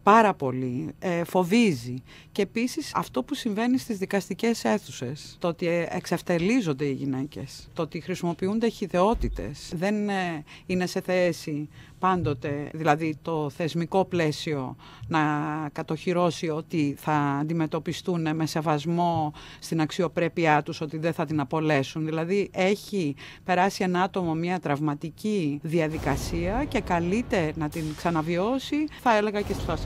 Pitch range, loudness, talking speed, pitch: 150-190 Hz, -27 LUFS, 125 wpm, 165 Hz